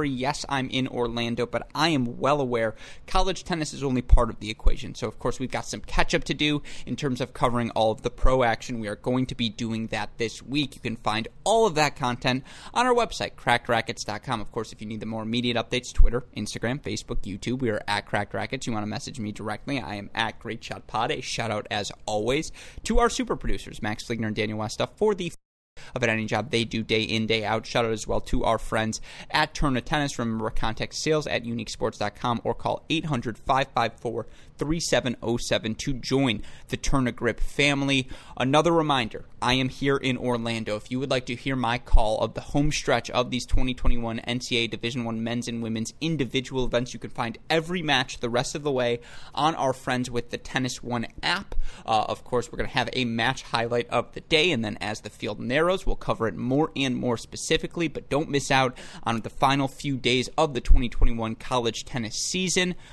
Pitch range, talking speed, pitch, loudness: 115-135 Hz, 210 wpm, 120 Hz, -27 LUFS